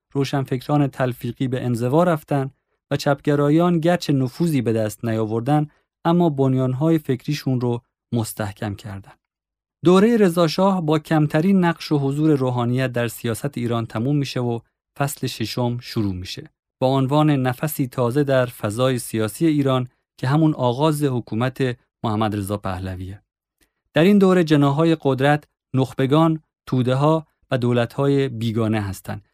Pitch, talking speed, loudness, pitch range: 135 Hz, 130 wpm, -20 LUFS, 120-150 Hz